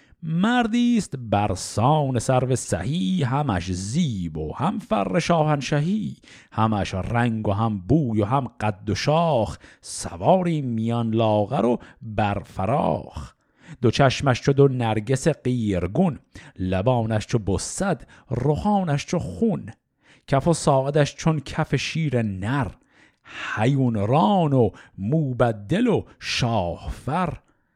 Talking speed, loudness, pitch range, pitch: 110 wpm, -23 LUFS, 110-155 Hz, 130 Hz